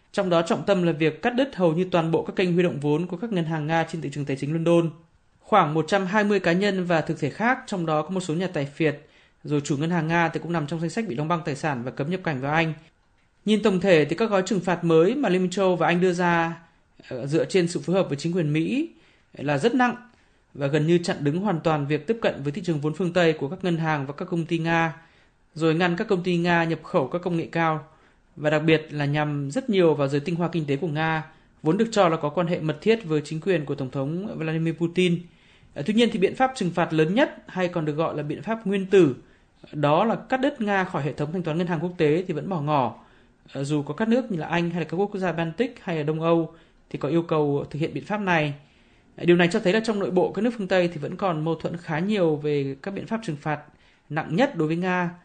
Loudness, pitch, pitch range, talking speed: -24 LUFS, 170 Hz, 155-185 Hz, 280 wpm